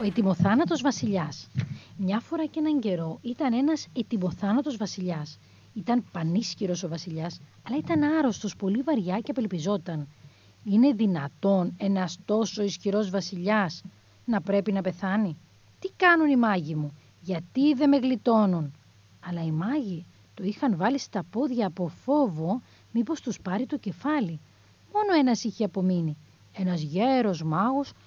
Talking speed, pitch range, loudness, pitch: 135 wpm, 175-250 Hz, -27 LUFS, 200 Hz